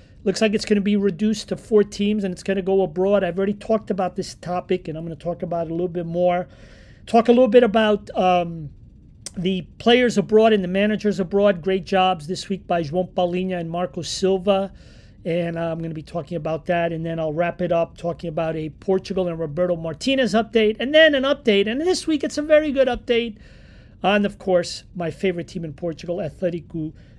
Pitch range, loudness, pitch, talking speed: 170-210 Hz, -21 LUFS, 185 Hz, 220 wpm